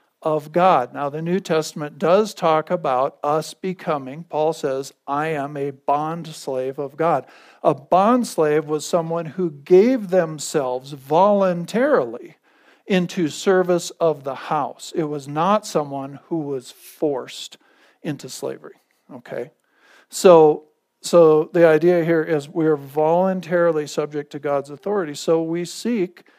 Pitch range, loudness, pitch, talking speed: 150-175 Hz, -20 LUFS, 160 Hz, 135 wpm